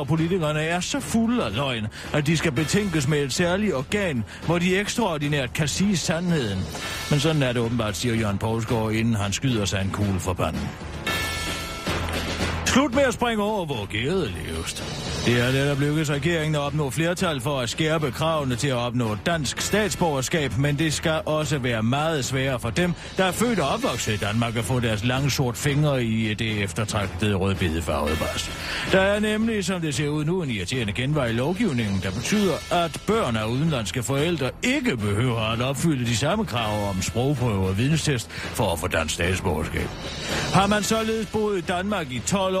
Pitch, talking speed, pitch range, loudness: 135 Hz, 190 wpm, 105-170 Hz, -24 LUFS